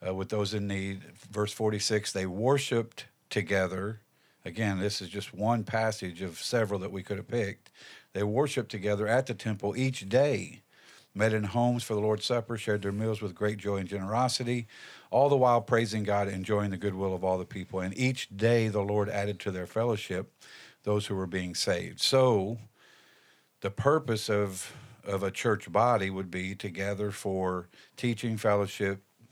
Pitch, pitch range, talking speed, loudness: 105 Hz, 95-115 Hz, 180 wpm, -30 LUFS